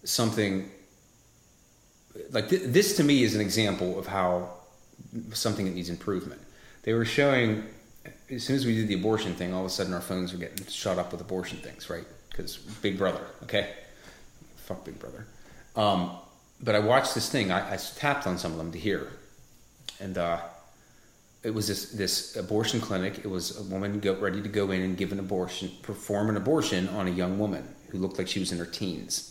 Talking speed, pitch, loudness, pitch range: 200 wpm, 95 Hz, -29 LUFS, 90-110 Hz